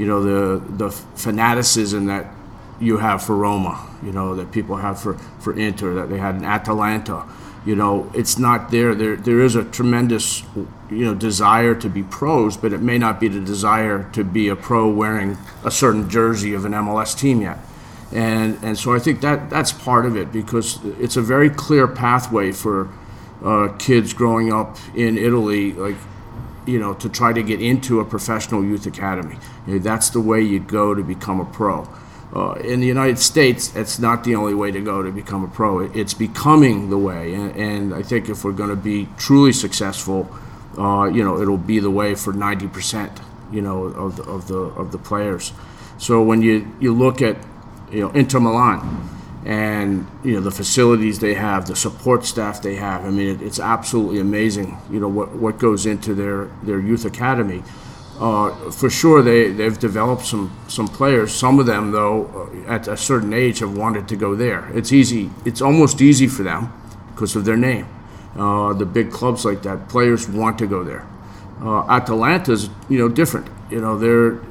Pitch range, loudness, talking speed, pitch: 100-115 Hz, -18 LUFS, 195 wpm, 110 Hz